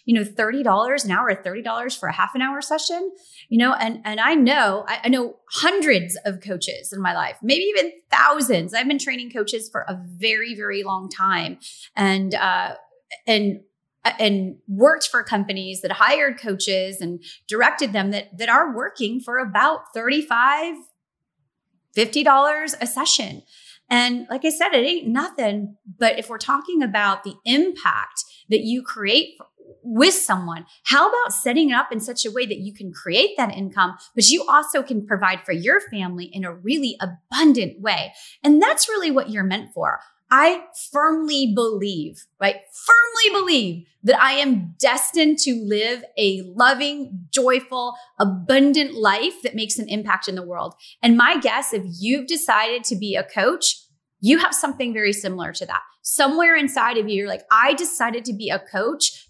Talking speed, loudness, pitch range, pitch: 170 wpm, -19 LUFS, 200-280 Hz, 235 Hz